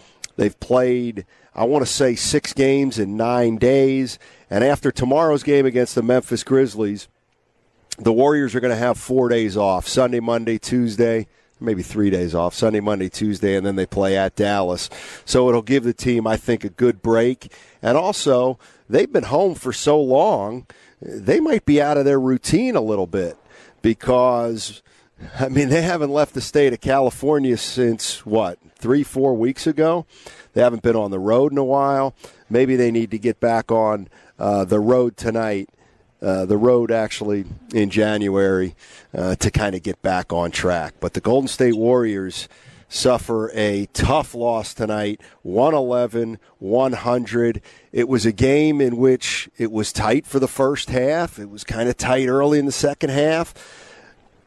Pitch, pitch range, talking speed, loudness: 120 Hz, 105-135 Hz, 175 wpm, -19 LUFS